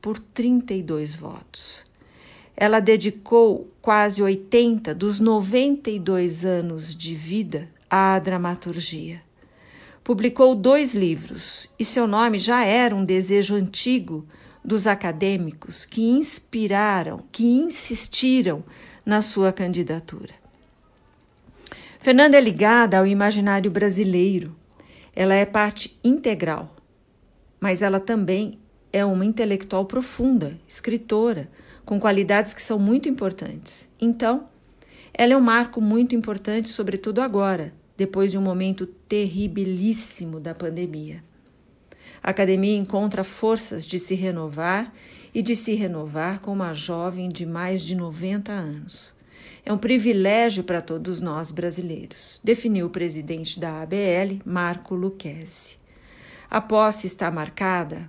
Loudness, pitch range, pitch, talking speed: -22 LUFS, 180-225 Hz, 200 Hz, 115 wpm